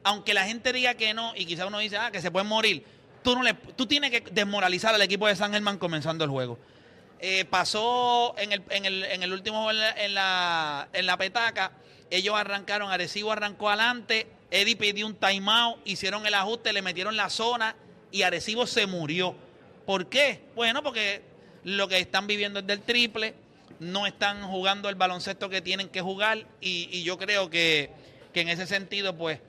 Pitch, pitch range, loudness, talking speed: 200 Hz, 185-220 Hz, -26 LUFS, 190 wpm